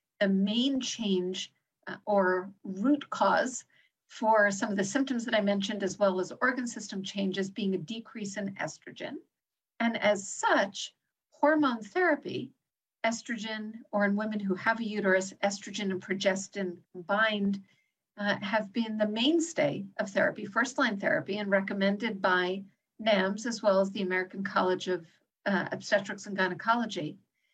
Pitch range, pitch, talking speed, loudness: 195-230 Hz, 205 Hz, 150 wpm, -30 LUFS